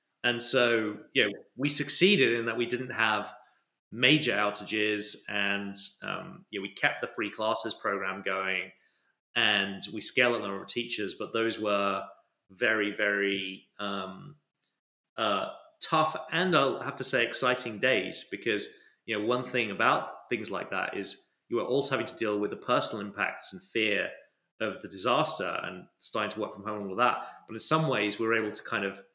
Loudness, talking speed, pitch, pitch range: -29 LUFS, 185 wpm, 110 Hz, 100-125 Hz